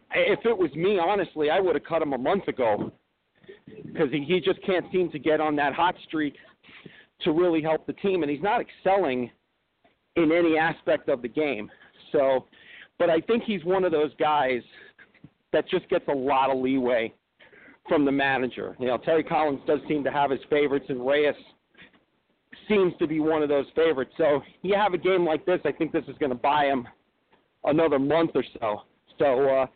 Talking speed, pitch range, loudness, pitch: 200 wpm, 140-180 Hz, -25 LUFS, 155 Hz